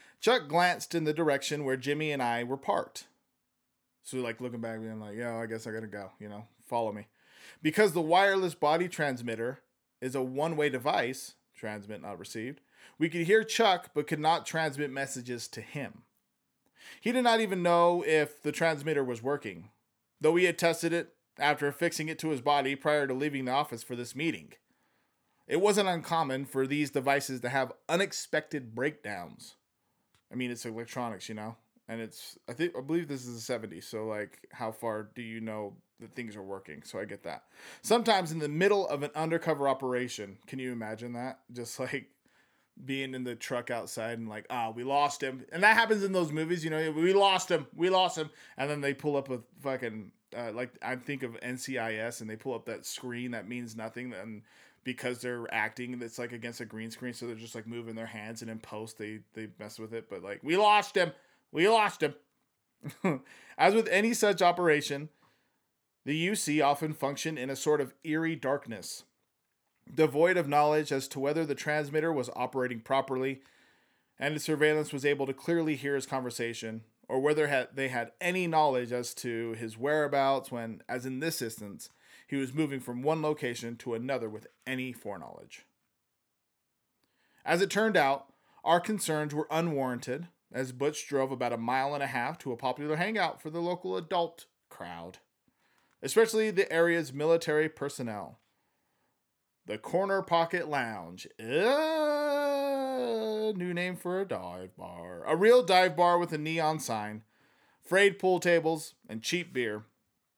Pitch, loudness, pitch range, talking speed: 140 Hz, -31 LUFS, 120-160 Hz, 180 wpm